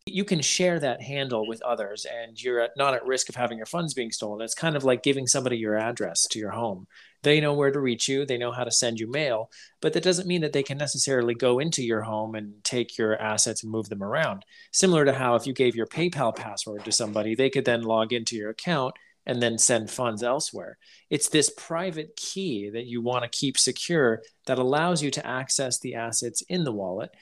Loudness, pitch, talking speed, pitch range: -26 LUFS, 125 Hz, 230 wpm, 115-145 Hz